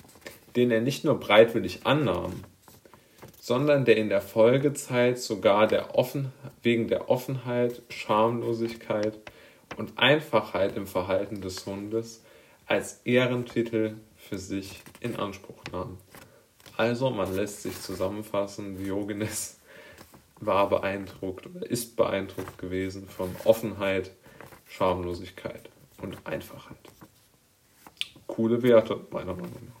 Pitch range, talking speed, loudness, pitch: 95-120 Hz, 105 wpm, -27 LUFS, 110 Hz